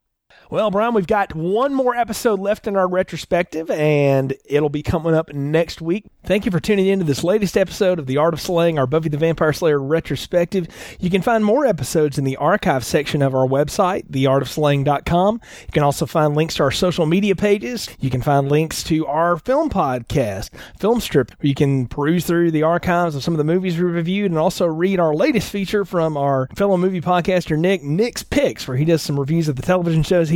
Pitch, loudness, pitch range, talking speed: 165 Hz, -19 LUFS, 145-190 Hz, 215 wpm